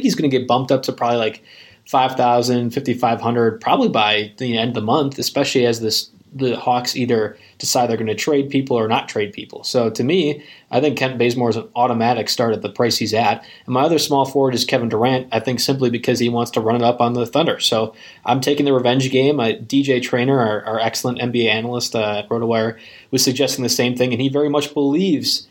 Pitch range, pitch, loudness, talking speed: 115-135 Hz, 125 Hz, -18 LUFS, 230 wpm